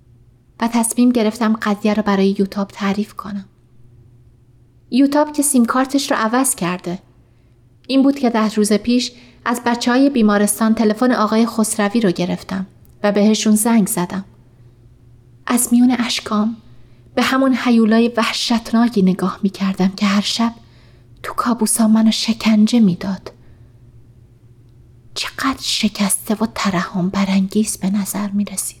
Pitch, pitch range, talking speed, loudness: 205 Hz, 175-230 Hz, 130 wpm, -17 LUFS